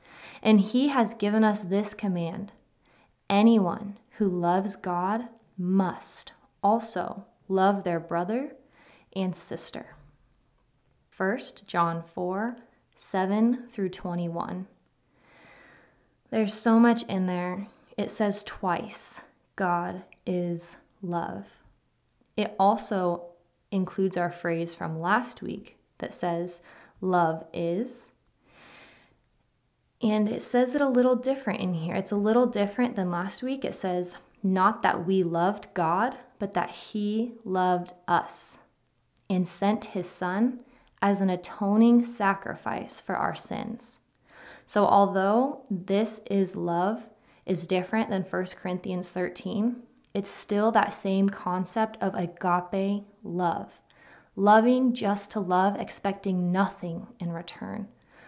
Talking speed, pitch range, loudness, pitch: 115 wpm, 180-220 Hz, -27 LUFS, 200 Hz